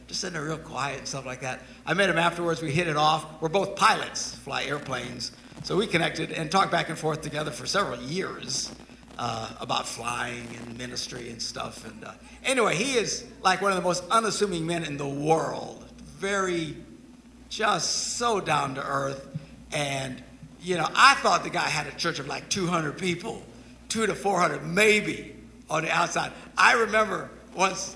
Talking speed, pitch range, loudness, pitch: 185 wpm, 150-195 Hz, -26 LUFS, 170 Hz